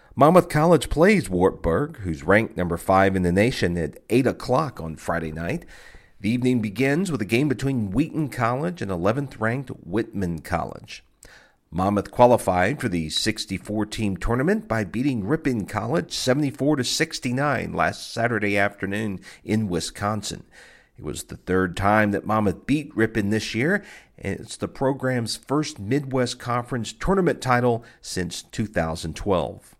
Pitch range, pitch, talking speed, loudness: 95-135 Hz, 110 Hz, 145 wpm, -23 LUFS